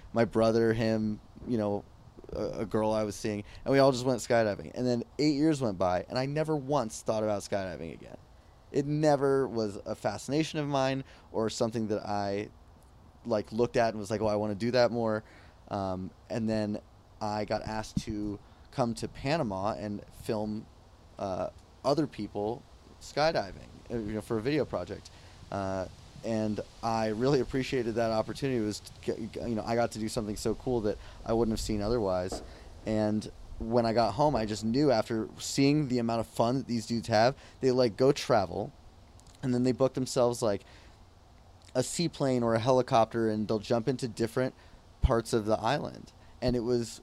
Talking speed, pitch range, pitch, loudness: 190 wpm, 105-125 Hz, 110 Hz, -31 LUFS